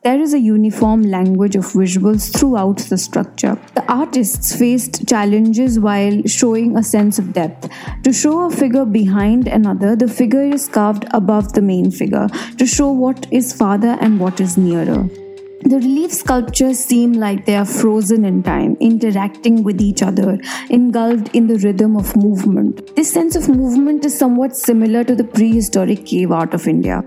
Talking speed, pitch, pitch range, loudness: 170 wpm, 225 Hz, 205-255 Hz, -14 LUFS